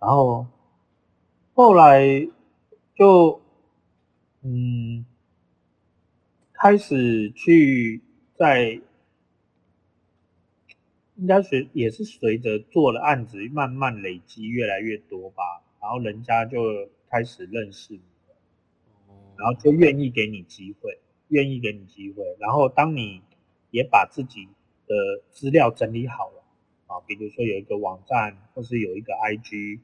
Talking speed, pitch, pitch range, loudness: 175 characters per minute, 115 Hz, 105-140 Hz, -21 LUFS